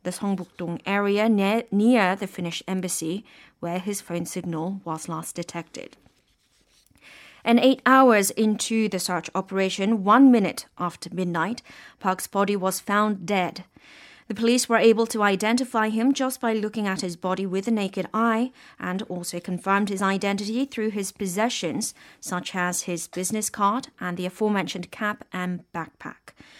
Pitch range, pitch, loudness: 180-225 Hz, 200 Hz, -24 LUFS